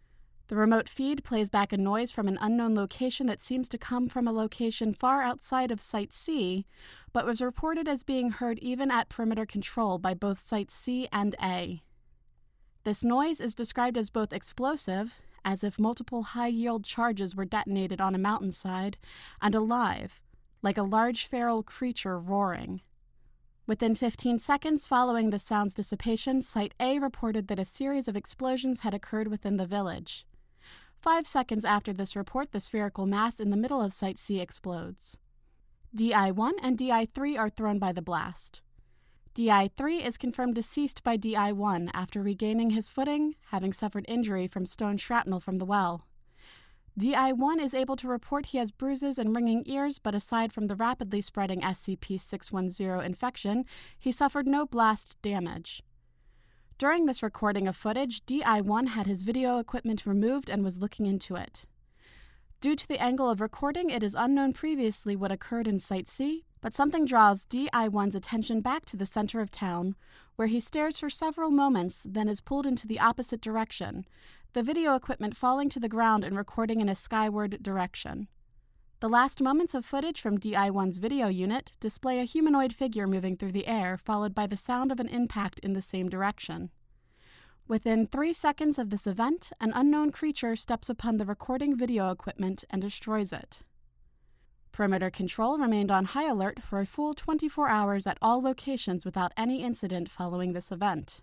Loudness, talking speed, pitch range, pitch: -30 LUFS, 175 wpm, 200-255 Hz, 220 Hz